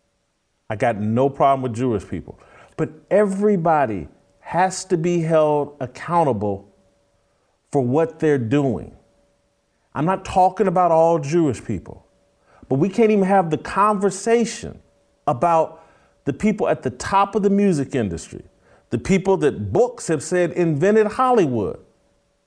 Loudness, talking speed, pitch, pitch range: -20 LUFS, 135 wpm, 160 Hz, 120-190 Hz